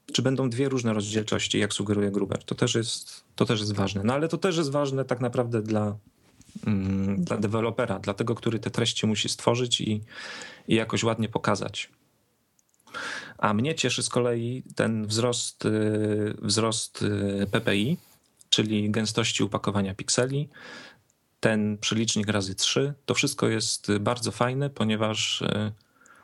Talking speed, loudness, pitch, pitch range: 150 wpm, -26 LUFS, 110 Hz, 105-120 Hz